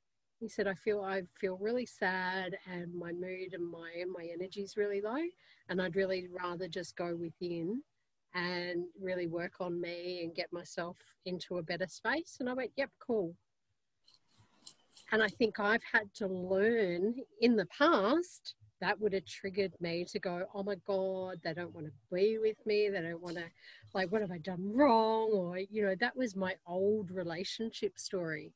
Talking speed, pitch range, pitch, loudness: 185 wpm, 175-210 Hz, 190 Hz, -36 LUFS